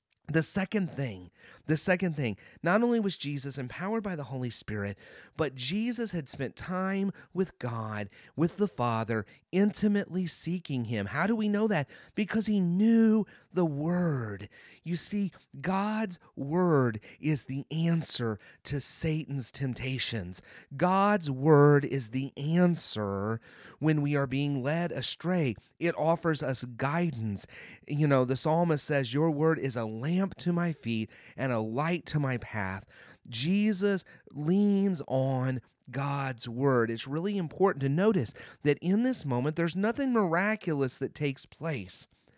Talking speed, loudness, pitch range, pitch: 145 wpm, -30 LUFS, 130-180 Hz, 150 Hz